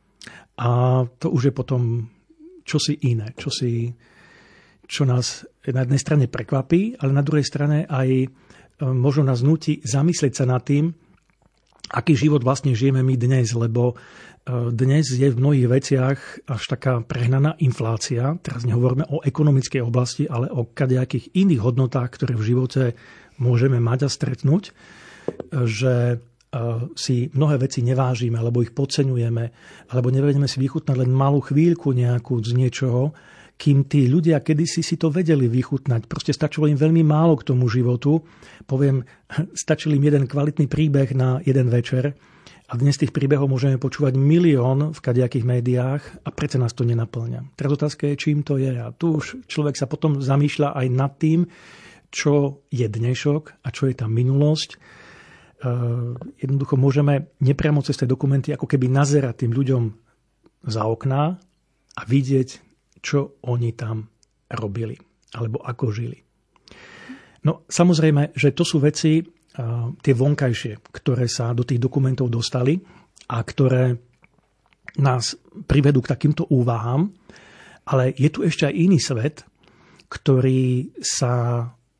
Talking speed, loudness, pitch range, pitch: 145 wpm, -21 LUFS, 125-150 Hz, 135 Hz